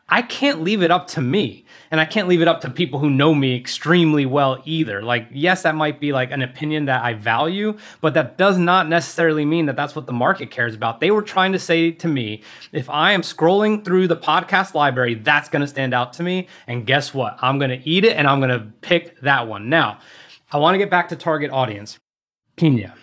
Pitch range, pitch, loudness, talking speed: 130-175 Hz, 155 Hz, -19 LUFS, 240 wpm